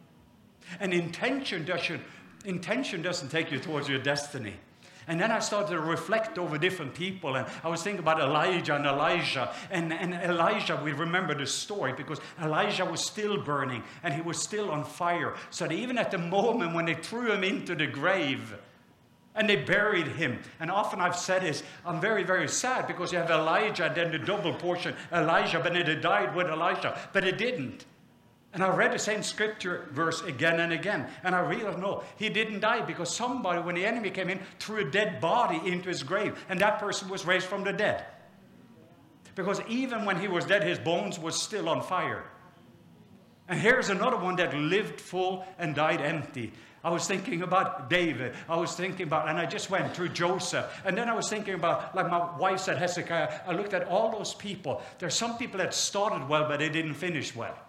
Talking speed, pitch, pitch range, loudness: 200 wpm, 180 Hz, 165-200 Hz, -29 LUFS